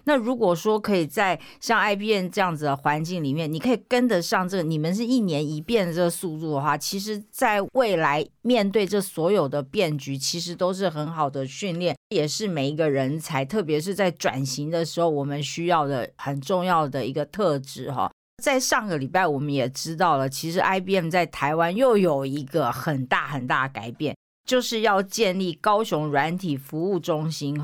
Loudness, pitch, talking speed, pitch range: -24 LUFS, 170 Hz, 295 characters per minute, 145-200 Hz